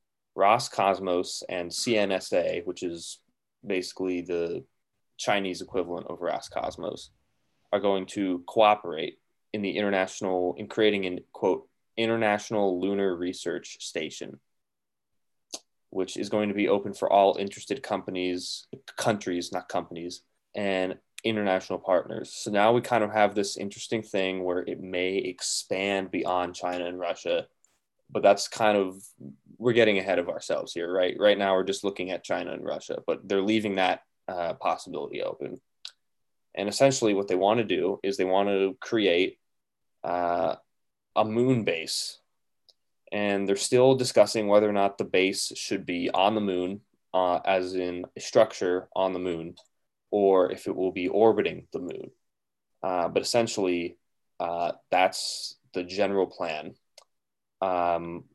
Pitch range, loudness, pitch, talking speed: 90-105 Hz, -27 LUFS, 95 Hz, 145 wpm